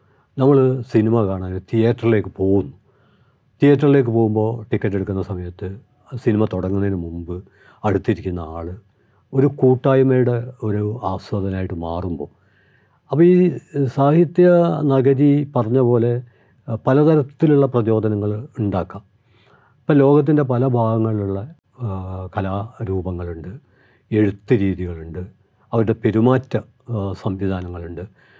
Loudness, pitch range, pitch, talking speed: -18 LUFS, 95-130 Hz, 110 Hz, 80 wpm